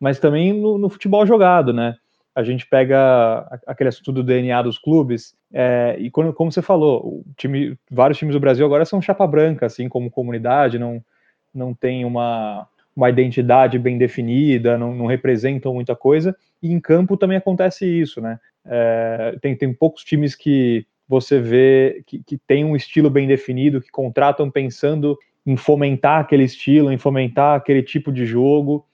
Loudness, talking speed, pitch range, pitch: -17 LUFS, 170 wpm, 125-150 Hz, 135 Hz